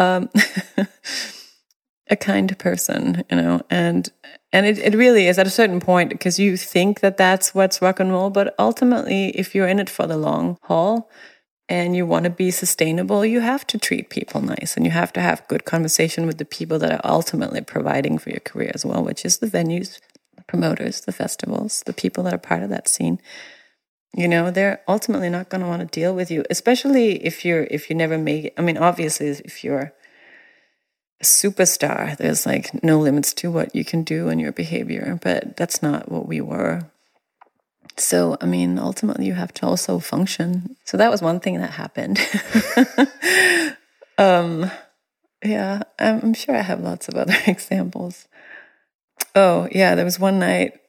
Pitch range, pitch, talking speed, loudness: 160-205 Hz, 185 Hz, 185 wpm, -19 LUFS